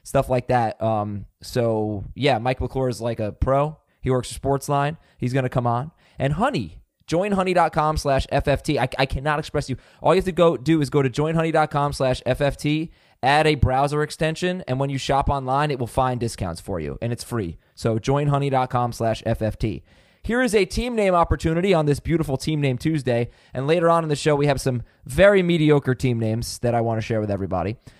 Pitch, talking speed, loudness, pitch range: 135 Hz, 210 wpm, -22 LUFS, 120-150 Hz